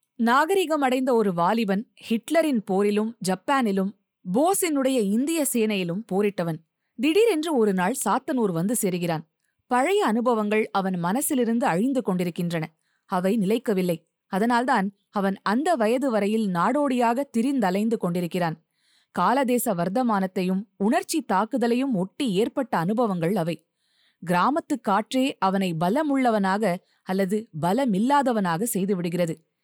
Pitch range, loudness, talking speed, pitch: 185-255 Hz, -24 LUFS, 95 wpm, 215 Hz